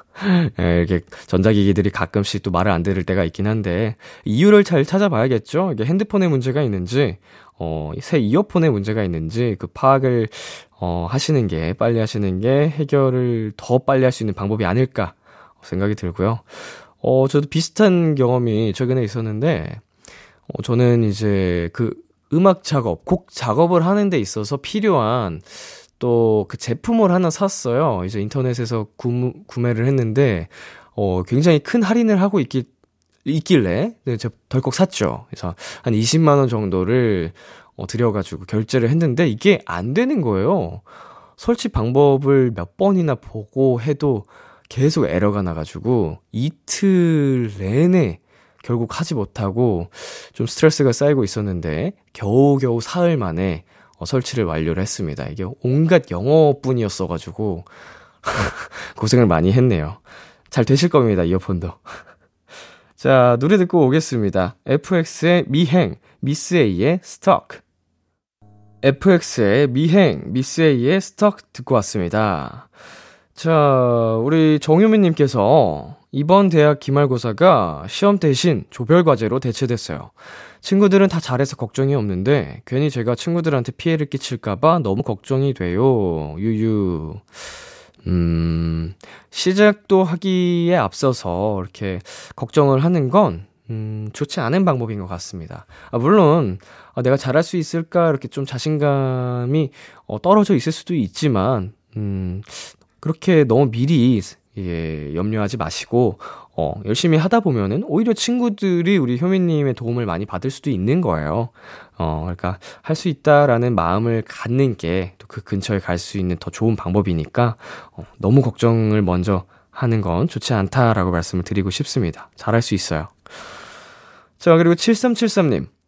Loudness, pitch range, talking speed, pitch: -18 LUFS, 100-155 Hz, 285 characters per minute, 125 Hz